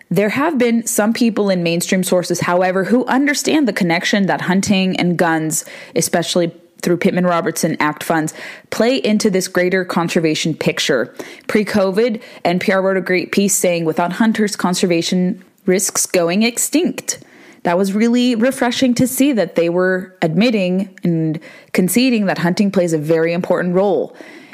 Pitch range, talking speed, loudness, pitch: 175-220 Hz, 150 wpm, -16 LUFS, 190 Hz